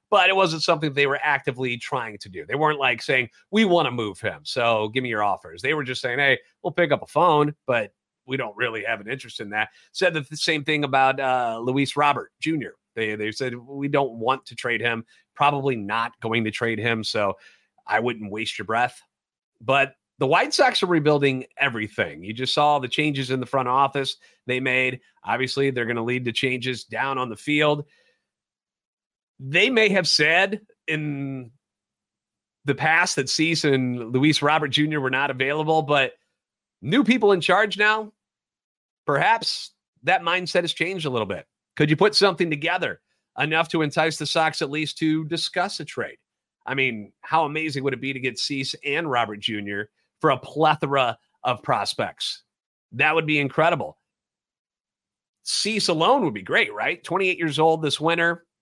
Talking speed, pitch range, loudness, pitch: 185 wpm, 130-165 Hz, -22 LUFS, 145 Hz